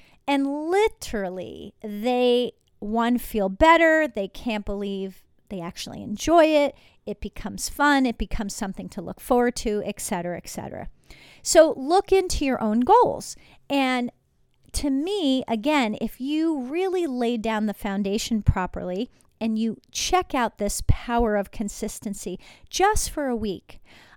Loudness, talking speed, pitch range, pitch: -24 LUFS, 140 wpm, 210-285 Hz, 235 Hz